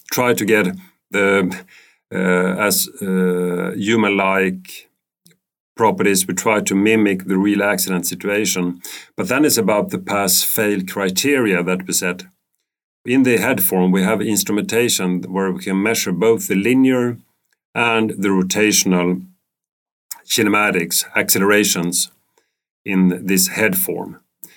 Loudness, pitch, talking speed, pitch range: -17 LUFS, 95 Hz, 120 wpm, 90-105 Hz